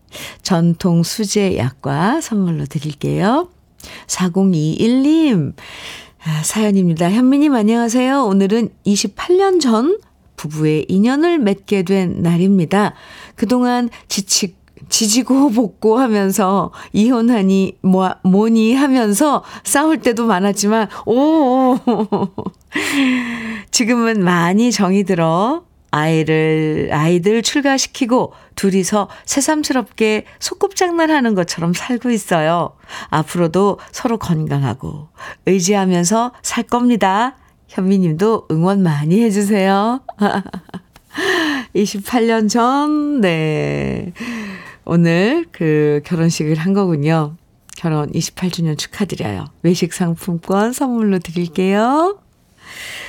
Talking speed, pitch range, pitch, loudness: 205 characters per minute, 175-245 Hz, 205 Hz, -16 LUFS